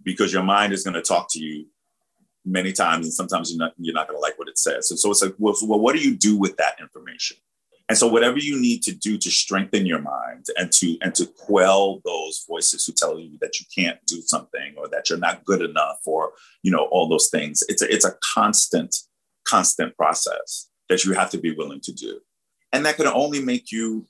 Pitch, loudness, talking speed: 125 Hz, -21 LUFS, 235 wpm